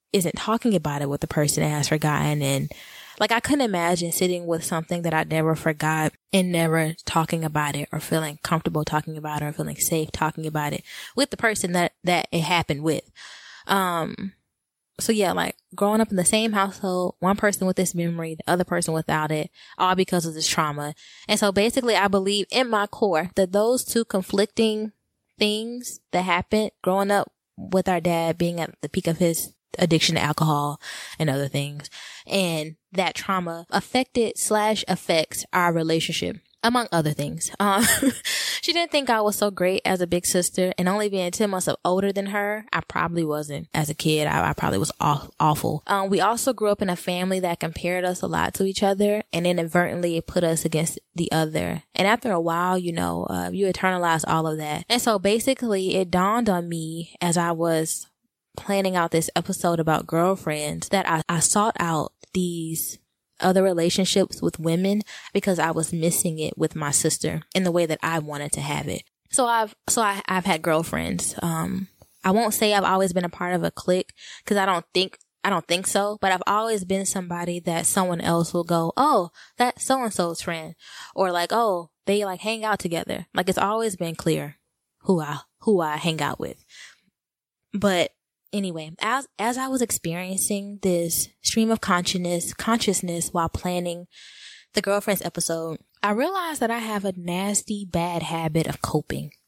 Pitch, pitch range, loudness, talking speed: 180 Hz, 165-200 Hz, -23 LUFS, 190 wpm